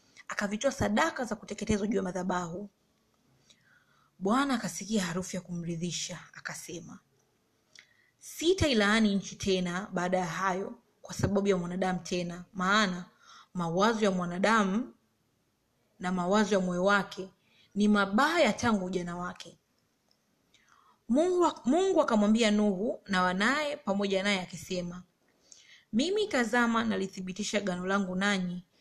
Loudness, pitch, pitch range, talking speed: -29 LUFS, 200 Hz, 185-220 Hz, 110 wpm